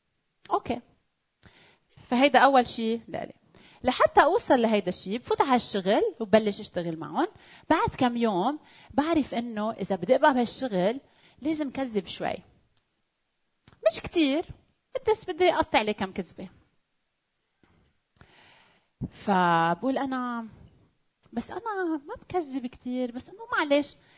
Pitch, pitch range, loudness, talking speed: 255 Hz, 220-315 Hz, -27 LUFS, 110 wpm